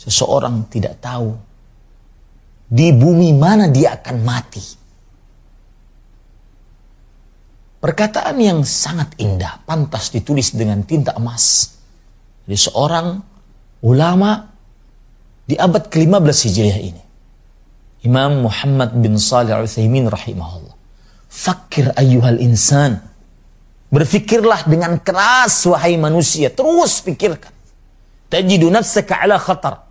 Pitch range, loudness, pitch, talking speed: 110-170 Hz, -14 LUFS, 130 Hz, 90 wpm